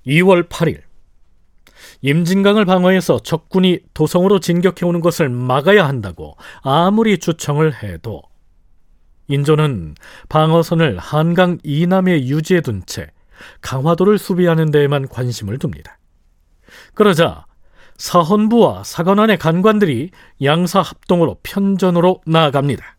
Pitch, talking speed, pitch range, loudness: 160 Hz, 265 characters per minute, 125-185 Hz, -15 LUFS